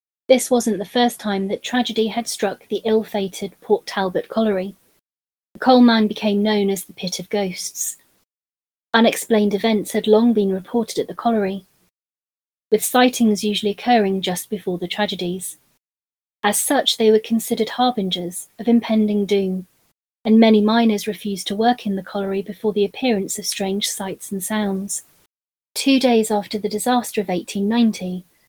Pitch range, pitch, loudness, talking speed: 195-225 Hz, 210 Hz, -19 LUFS, 160 wpm